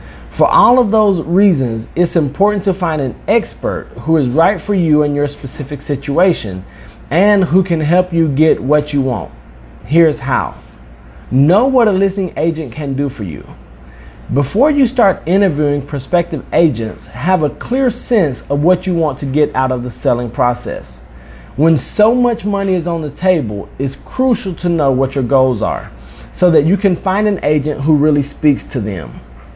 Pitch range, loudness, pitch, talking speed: 125-185 Hz, -14 LUFS, 150 Hz, 180 wpm